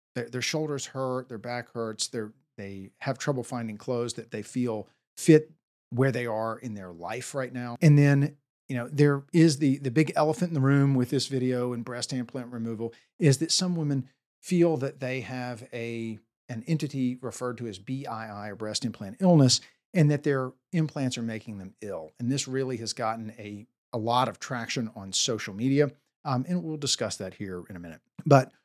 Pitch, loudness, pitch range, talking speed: 125 Hz, -28 LUFS, 115-140 Hz, 200 wpm